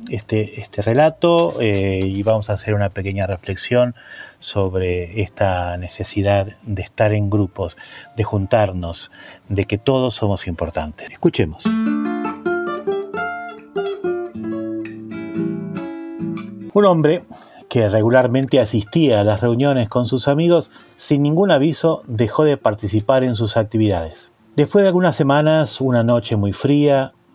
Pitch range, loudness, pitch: 100-145 Hz, -18 LUFS, 115 Hz